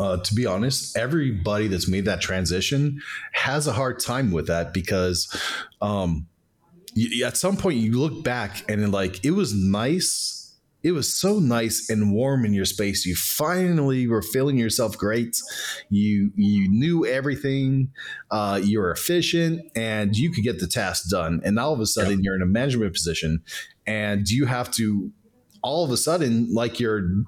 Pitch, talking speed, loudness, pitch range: 110 Hz, 175 wpm, -23 LUFS, 100-135 Hz